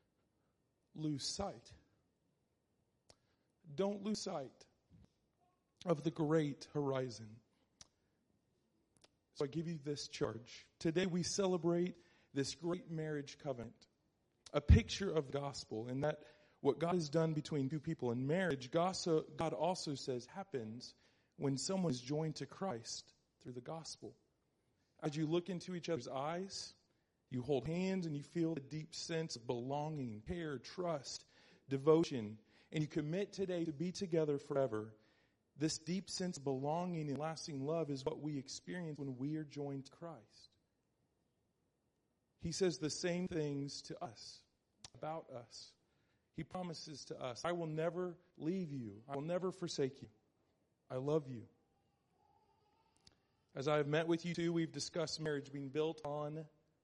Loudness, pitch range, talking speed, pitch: -41 LUFS, 135-170 Hz, 145 wpm, 155 Hz